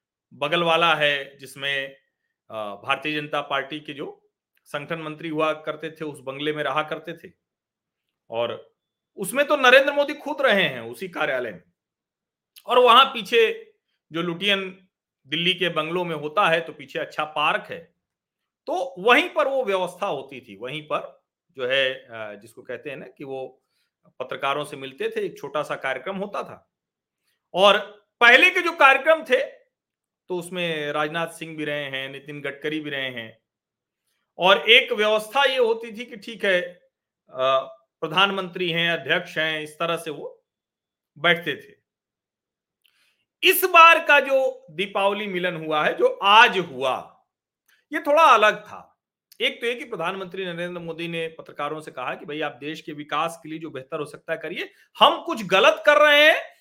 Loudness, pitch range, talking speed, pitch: -21 LUFS, 150-240 Hz, 165 wpm, 170 Hz